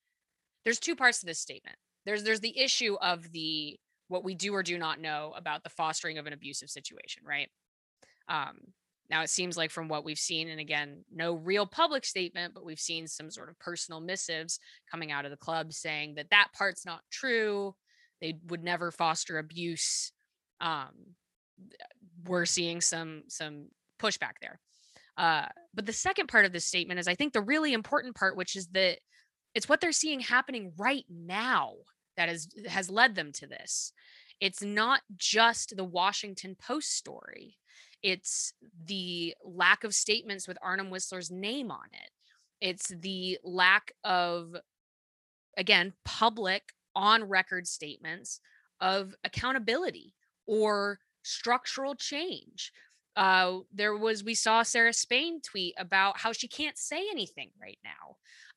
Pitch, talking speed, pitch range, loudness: 190 Hz, 155 wpm, 170-225 Hz, -30 LUFS